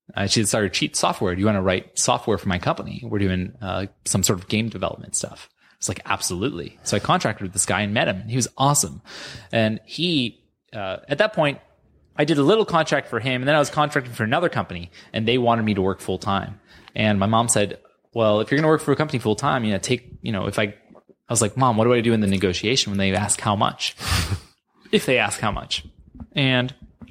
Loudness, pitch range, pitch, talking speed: -22 LUFS, 100-130 Hz, 110 Hz, 250 wpm